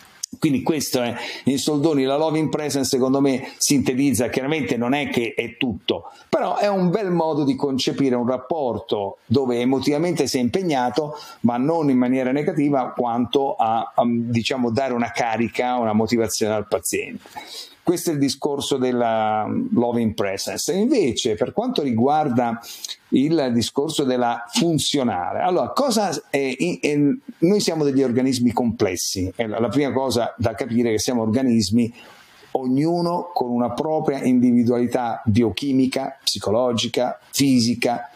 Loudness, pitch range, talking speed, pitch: -21 LUFS, 120-145 Hz, 145 wpm, 130 Hz